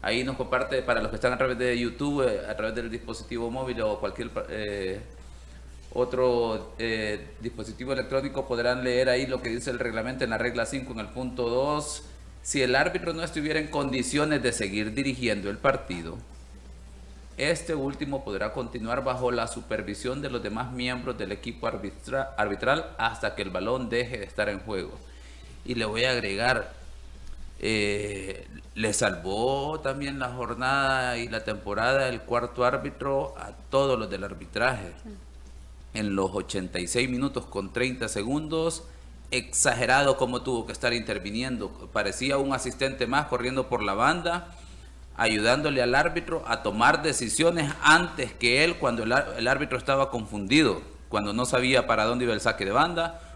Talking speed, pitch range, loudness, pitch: 160 wpm, 105-135 Hz, -27 LUFS, 125 Hz